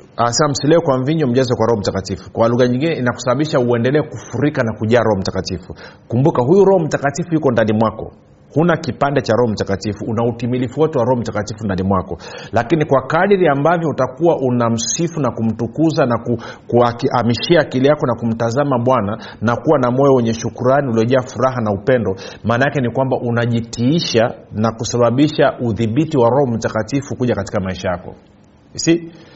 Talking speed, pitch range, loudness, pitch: 150 wpm, 115-140 Hz, -16 LUFS, 120 Hz